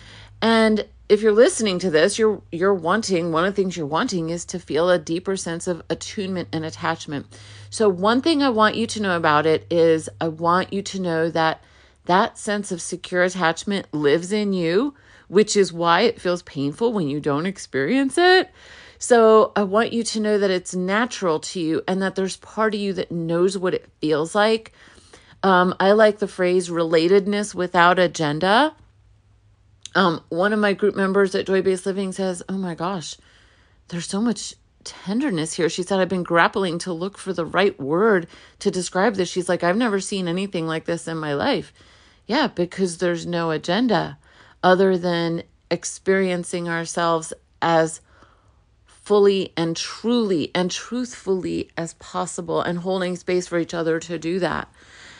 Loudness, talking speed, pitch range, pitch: -21 LUFS, 175 wpm, 165-200 Hz, 180 Hz